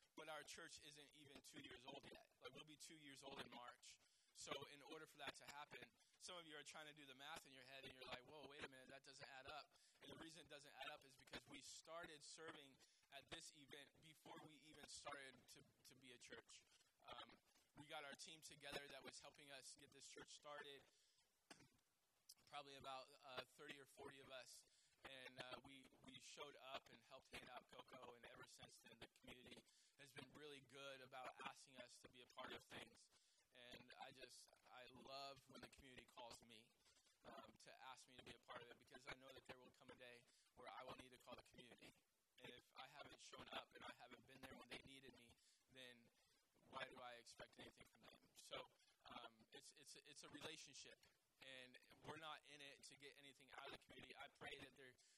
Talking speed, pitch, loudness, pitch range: 225 wpm, 135 Hz, -61 LUFS, 130-145 Hz